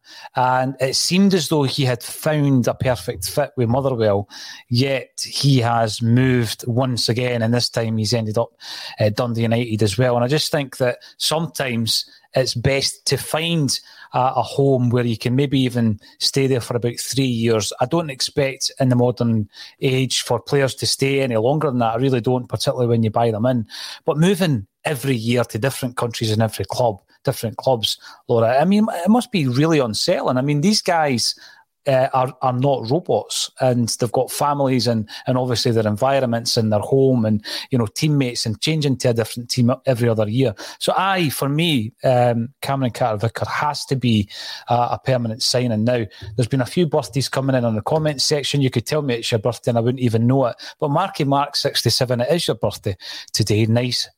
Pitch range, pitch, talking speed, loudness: 115-135 Hz, 125 Hz, 200 wpm, -19 LUFS